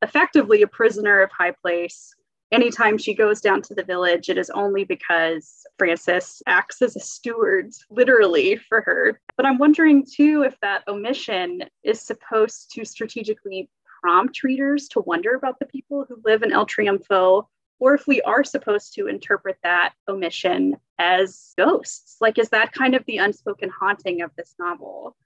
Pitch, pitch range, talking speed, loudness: 220 Hz, 190-275 Hz, 165 wpm, -20 LUFS